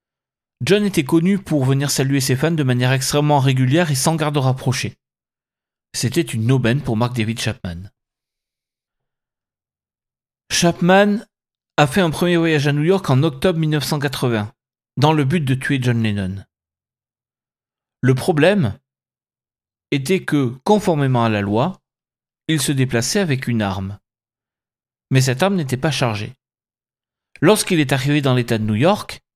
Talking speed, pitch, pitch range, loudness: 145 wpm, 130 Hz, 115-155 Hz, -18 LUFS